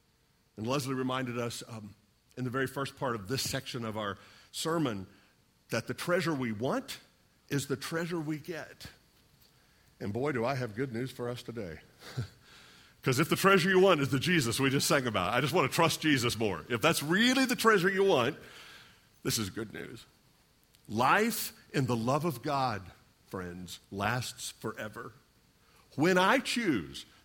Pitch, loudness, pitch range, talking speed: 135 Hz, -30 LUFS, 115-165 Hz, 175 wpm